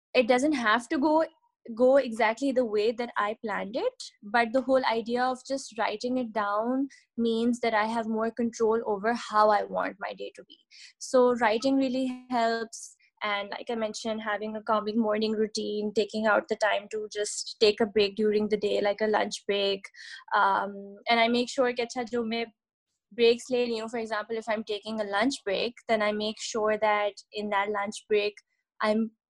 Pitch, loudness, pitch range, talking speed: 225 Hz, -28 LUFS, 215-245 Hz, 195 wpm